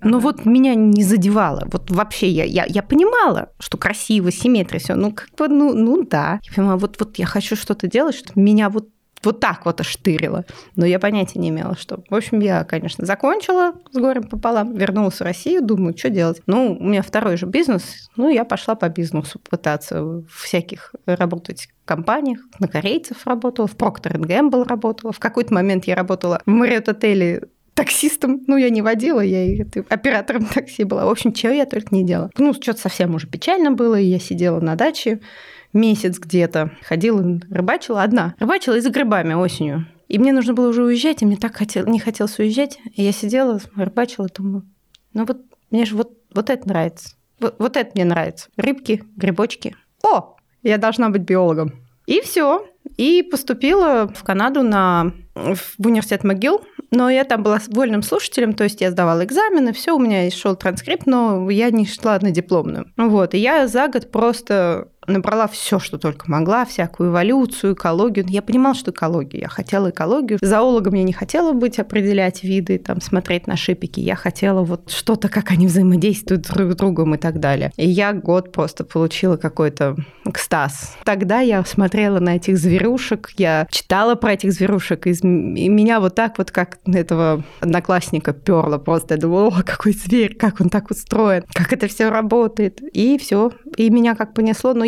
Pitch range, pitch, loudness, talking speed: 180-235 Hz, 205 Hz, -18 LUFS, 180 wpm